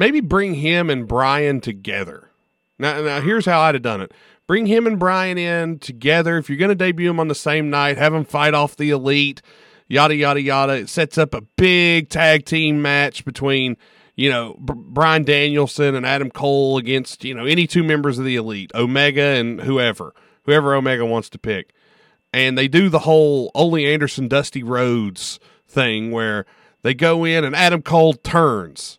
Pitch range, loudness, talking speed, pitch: 130-160 Hz, -17 LUFS, 185 wpm, 145 Hz